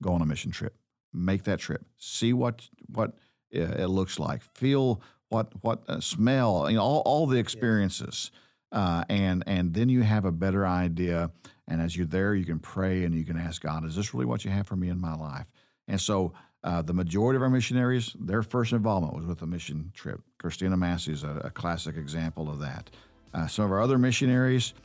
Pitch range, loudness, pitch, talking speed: 85-115 Hz, -28 LUFS, 95 Hz, 210 wpm